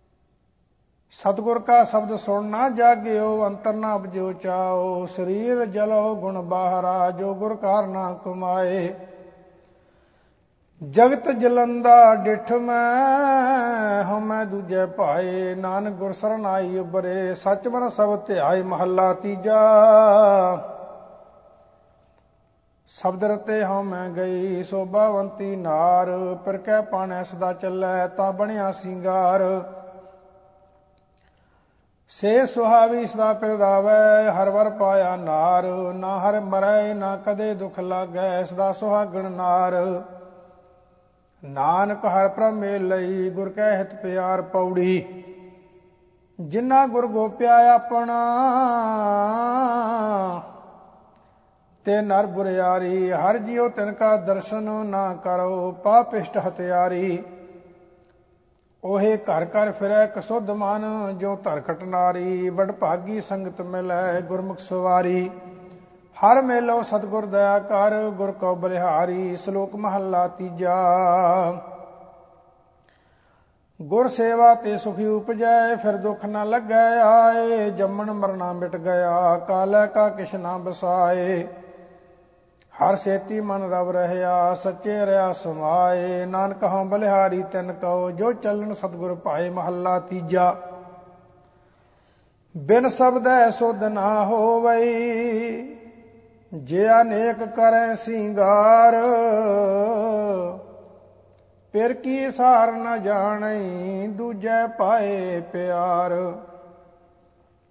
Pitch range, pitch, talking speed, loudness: 180-215 Hz, 195 Hz, 95 wpm, -21 LUFS